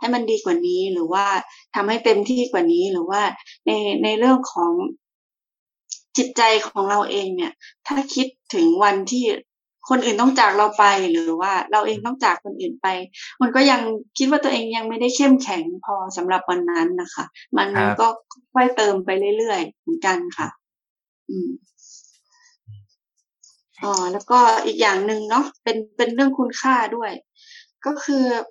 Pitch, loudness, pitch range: 250 Hz, -20 LUFS, 210-330 Hz